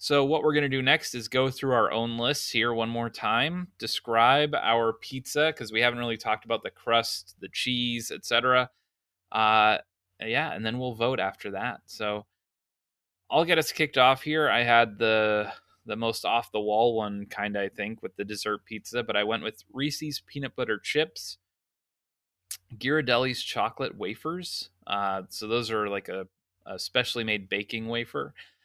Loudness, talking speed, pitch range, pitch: -27 LUFS, 175 wpm, 105-130 Hz, 115 Hz